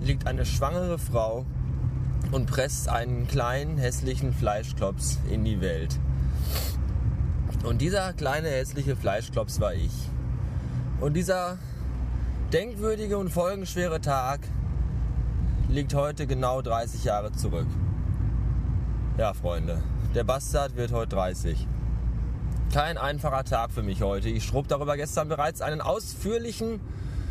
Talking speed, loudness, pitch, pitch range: 115 wpm, -28 LUFS, 115 Hz, 95-135 Hz